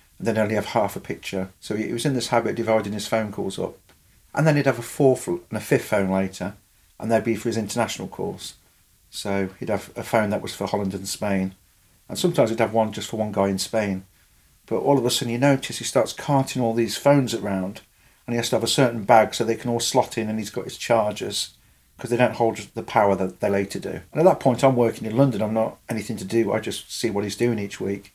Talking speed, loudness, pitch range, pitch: 260 wpm, -23 LUFS, 100-120 Hz, 110 Hz